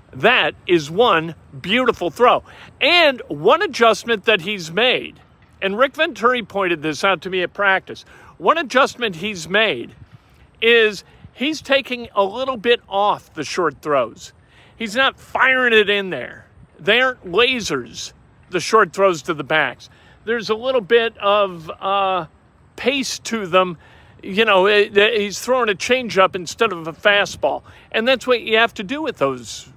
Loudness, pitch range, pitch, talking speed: -18 LUFS, 185-245 Hz, 210 Hz, 155 wpm